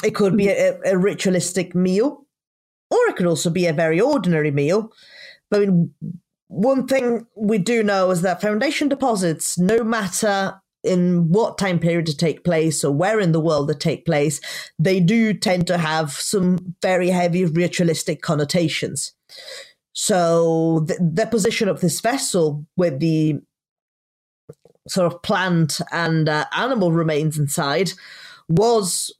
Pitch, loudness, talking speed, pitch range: 175 Hz, -19 LUFS, 150 wpm, 165-205 Hz